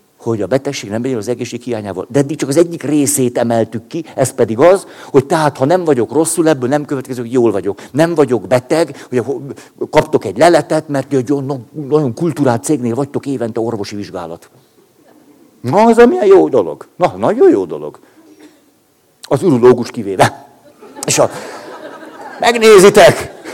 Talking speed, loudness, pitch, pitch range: 160 wpm, -13 LUFS, 140 Hz, 120-170 Hz